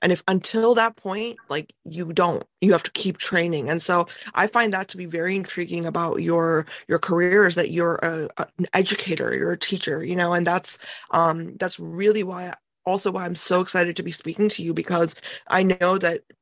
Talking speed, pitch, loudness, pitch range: 210 wpm, 180 Hz, -23 LUFS, 170-190 Hz